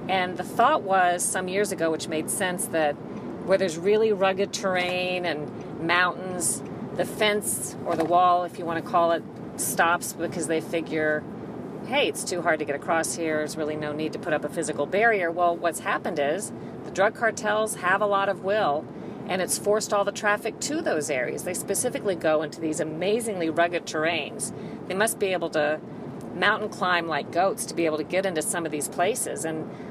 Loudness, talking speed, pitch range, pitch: -25 LUFS, 200 wpm, 160-195 Hz, 175 Hz